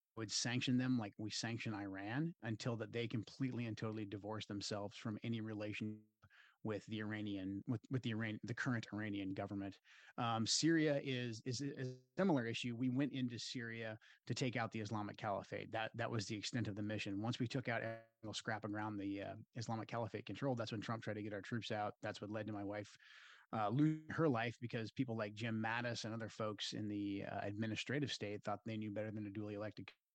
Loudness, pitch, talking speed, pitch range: -43 LUFS, 110 Hz, 215 wpm, 105-120 Hz